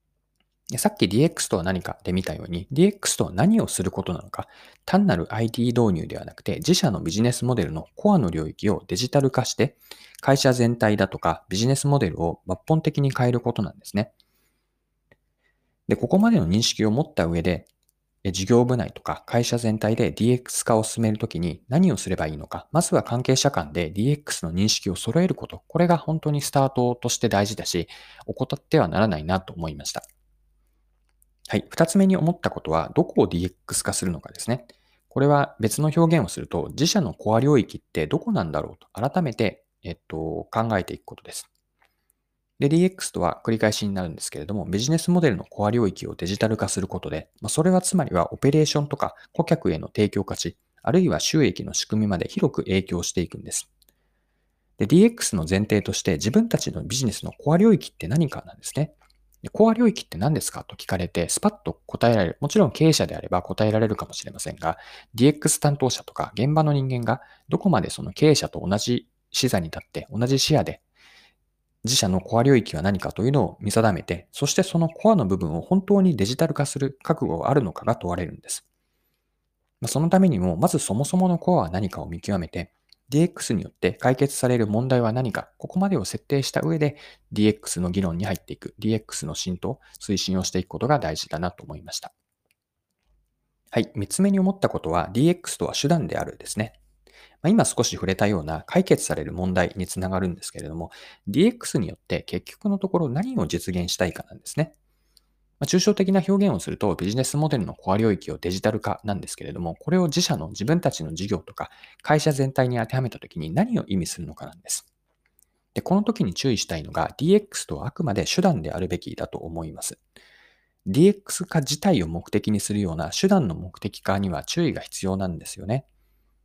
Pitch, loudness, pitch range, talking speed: 115 Hz, -23 LUFS, 95-155 Hz, 390 characters per minute